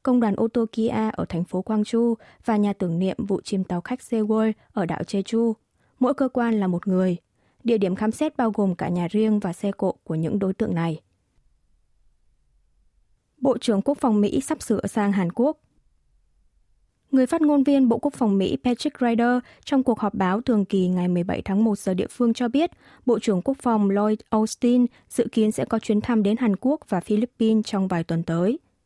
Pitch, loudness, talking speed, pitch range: 215 Hz, -23 LUFS, 205 wpm, 185-240 Hz